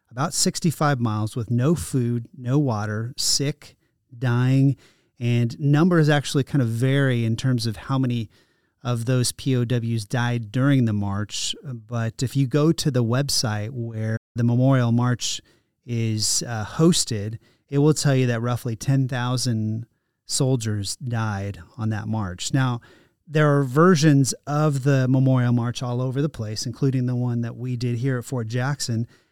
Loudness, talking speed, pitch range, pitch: -22 LUFS, 155 wpm, 115-135 Hz, 125 Hz